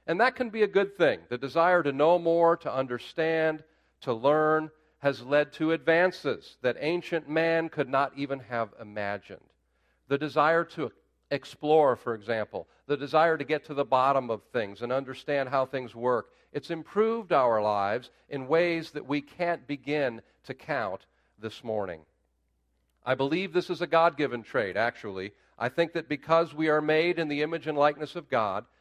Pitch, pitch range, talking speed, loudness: 150 Hz, 125-165 Hz, 175 wpm, -28 LUFS